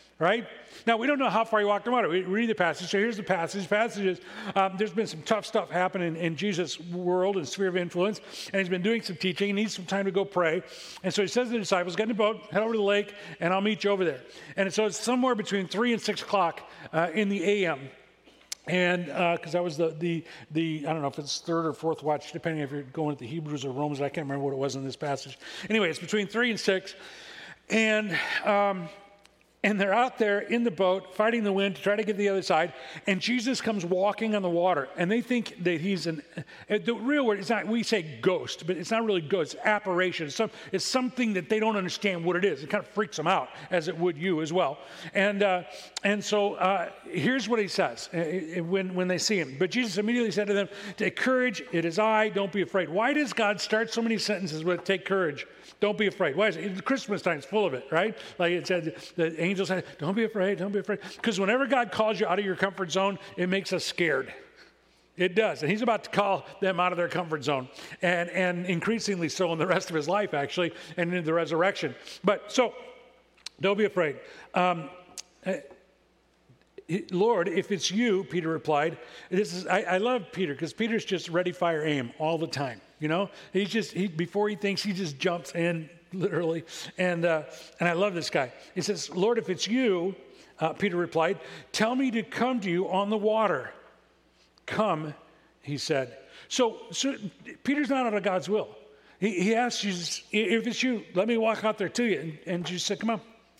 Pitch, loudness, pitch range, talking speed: 190 Hz, -28 LUFS, 175-215 Hz, 230 wpm